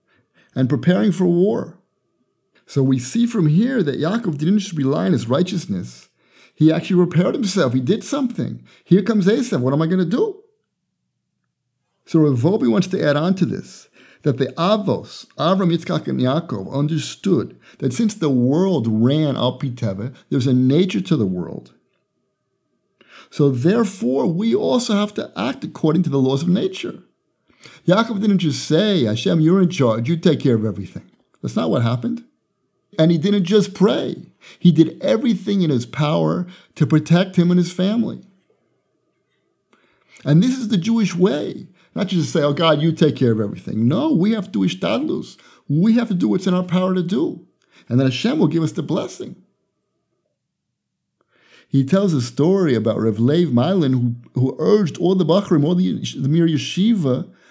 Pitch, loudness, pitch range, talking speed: 170 Hz, -18 LUFS, 140-195 Hz, 175 wpm